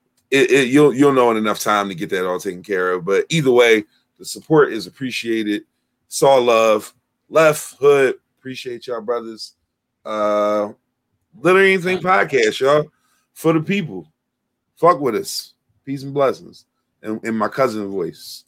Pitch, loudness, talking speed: 135 Hz, -17 LUFS, 155 wpm